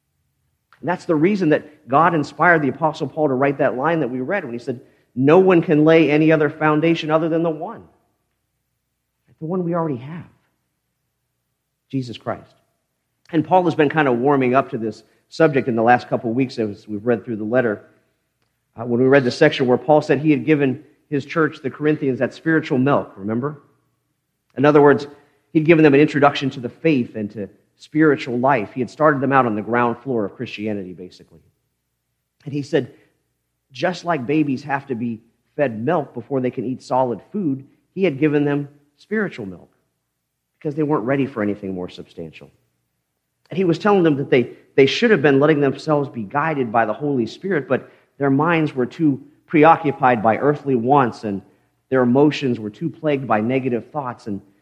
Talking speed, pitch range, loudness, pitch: 195 wpm, 120-155 Hz, -19 LUFS, 140 Hz